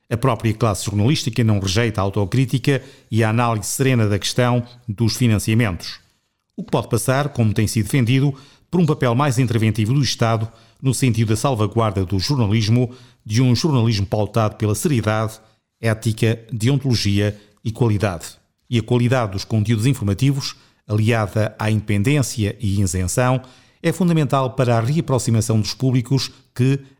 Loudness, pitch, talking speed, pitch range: -19 LUFS, 120 Hz, 145 wpm, 110-130 Hz